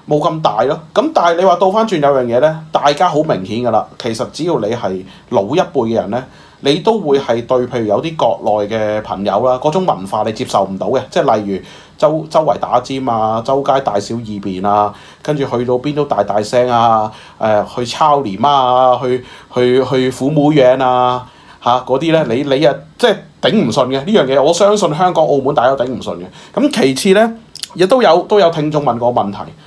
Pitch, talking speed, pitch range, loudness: 130 Hz, 295 characters per minute, 115-150 Hz, -14 LUFS